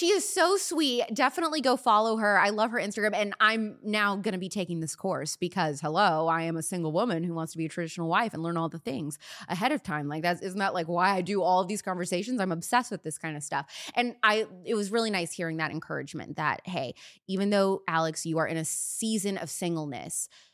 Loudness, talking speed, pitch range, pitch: -28 LUFS, 240 wpm, 165-215 Hz, 190 Hz